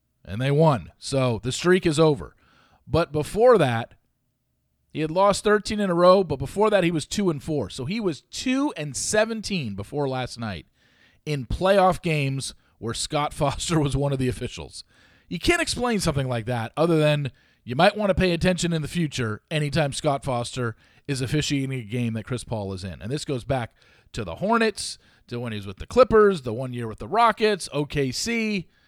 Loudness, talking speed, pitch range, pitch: -24 LUFS, 200 wpm, 120-185 Hz, 145 Hz